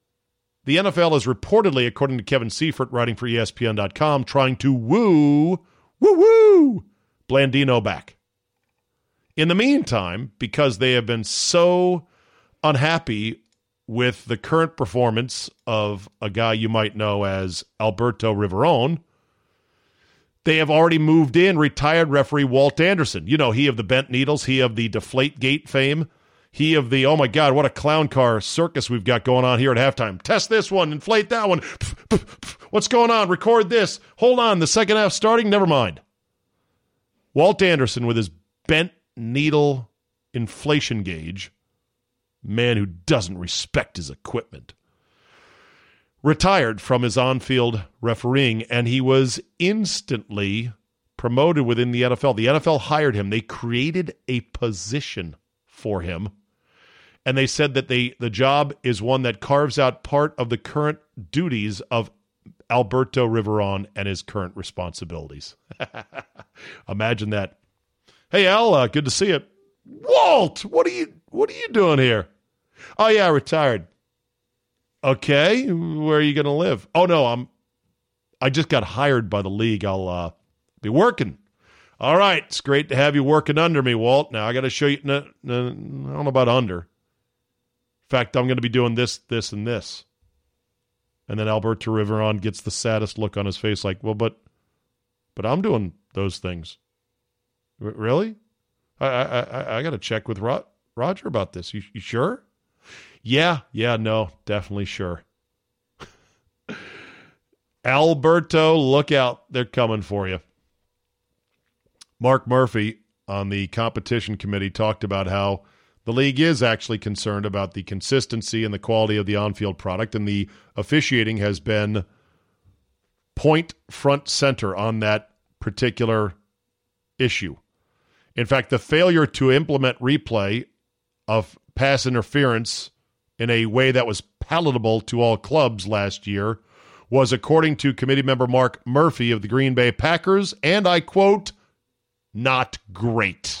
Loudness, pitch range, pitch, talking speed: -20 LUFS, 105-145 Hz, 120 Hz, 150 wpm